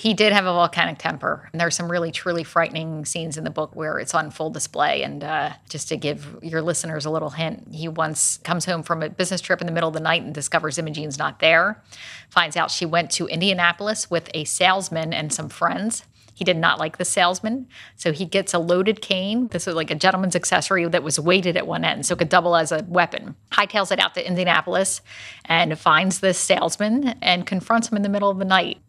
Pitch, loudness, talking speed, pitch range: 175 Hz, -21 LUFS, 230 wpm, 160-190 Hz